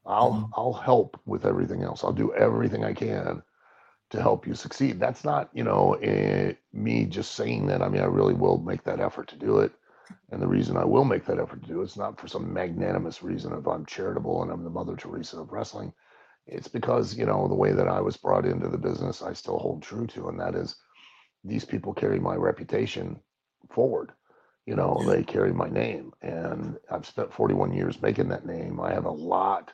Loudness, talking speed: -27 LUFS, 220 wpm